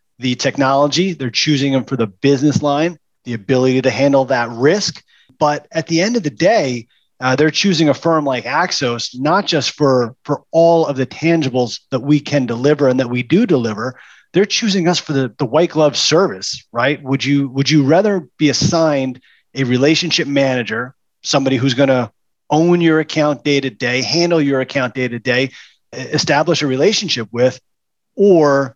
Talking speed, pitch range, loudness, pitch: 180 wpm, 130-155 Hz, -15 LUFS, 140 Hz